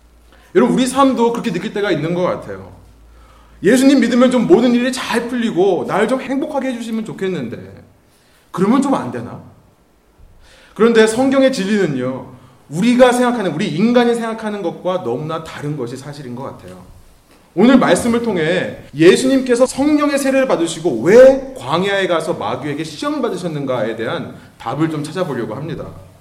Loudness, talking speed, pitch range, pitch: -15 LUFS, 350 characters per minute, 160-255 Hz, 205 Hz